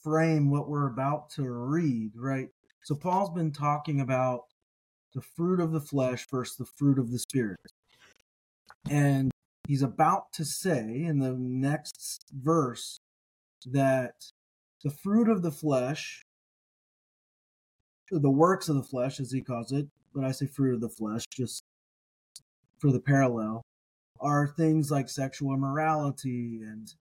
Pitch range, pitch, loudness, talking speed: 125-150 Hz, 135 Hz, -29 LUFS, 140 wpm